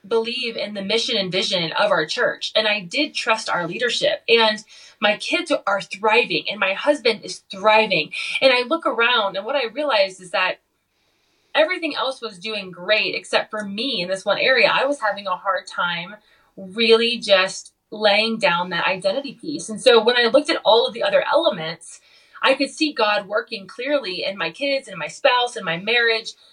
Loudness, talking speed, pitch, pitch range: -19 LUFS, 195 wpm, 225 Hz, 195-270 Hz